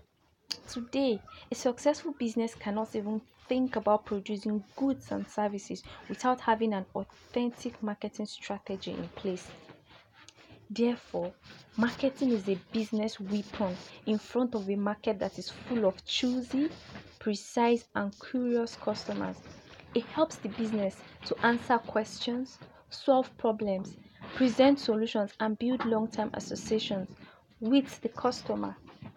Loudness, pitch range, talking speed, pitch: -32 LUFS, 200-245 Hz, 120 wpm, 220 Hz